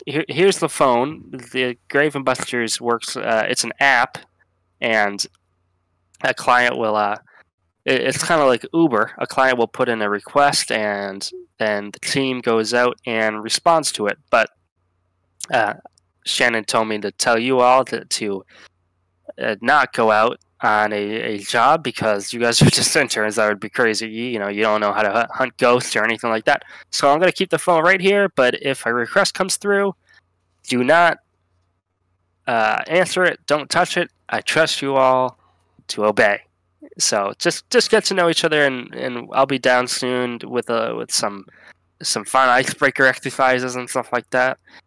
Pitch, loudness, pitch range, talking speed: 120 Hz, -18 LUFS, 105-135 Hz, 185 wpm